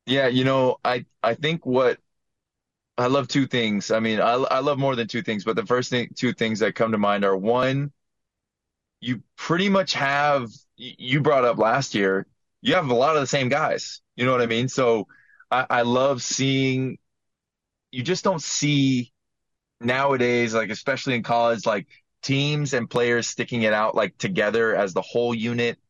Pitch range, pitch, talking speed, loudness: 115-135 Hz, 125 Hz, 190 wpm, -22 LUFS